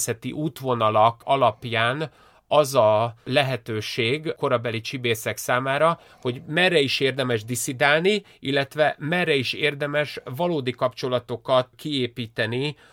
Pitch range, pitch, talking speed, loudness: 120-150 Hz, 130 Hz, 95 wpm, -23 LUFS